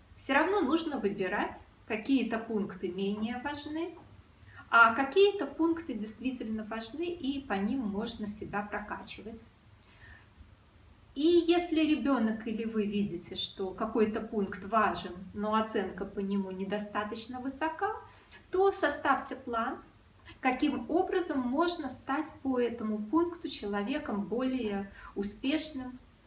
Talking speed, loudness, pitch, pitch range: 110 wpm, -32 LUFS, 230 Hz, 205-290 Hz